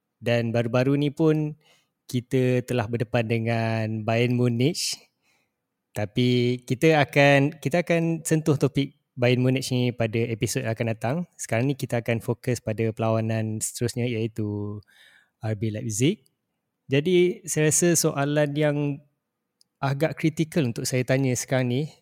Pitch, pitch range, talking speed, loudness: 130 Hz, 115-150 Hz, 130 wpm, -24 LUFS